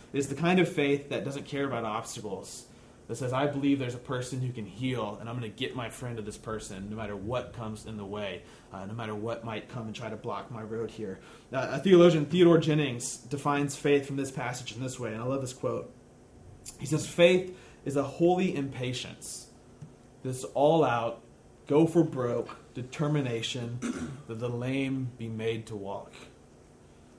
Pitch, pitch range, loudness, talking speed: 125 Hz, 115-145 Hz, -30 LUFS, 195 wpm